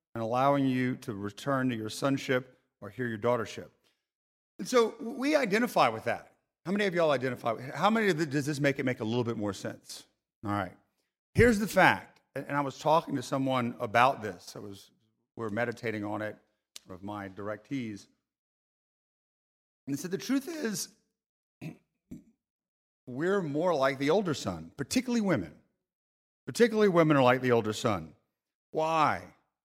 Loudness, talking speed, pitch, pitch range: -29 LUFS, 170 wpm, 130 Hz, 110-165 Hz